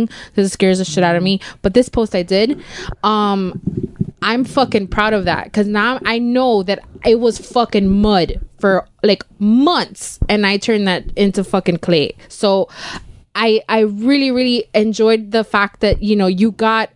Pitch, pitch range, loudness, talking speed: 210 Hz, 195-225 Hz, -16 LUFS, 180 wpm